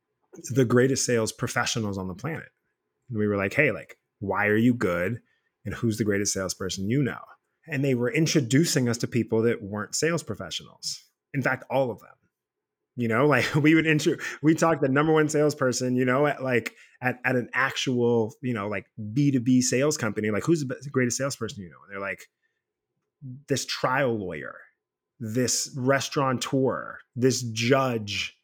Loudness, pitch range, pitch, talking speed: -25 LUFS, 110-145 Hz, 125 Hz, 185 wpm